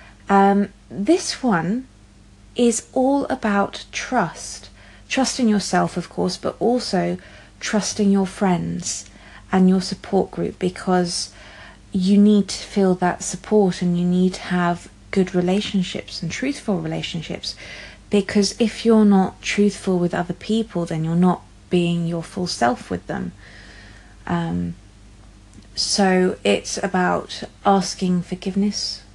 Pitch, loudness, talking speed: 180 Hz, -21 LUFS, 125 wpm